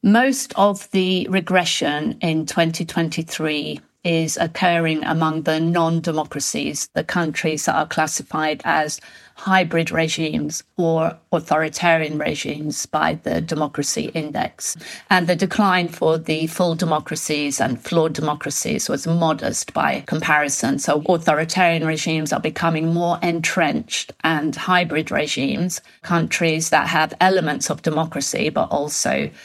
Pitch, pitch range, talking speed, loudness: 165 Hz, 155-175 Hz, 120 wpm, -20 LUFS